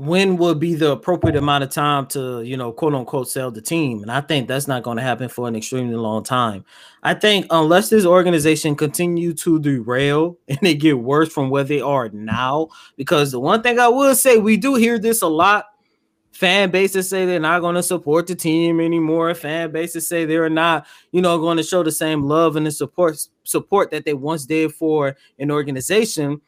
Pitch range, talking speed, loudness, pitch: 140-175 Hz, 215 wpm, -18 LUFS, 160 Hz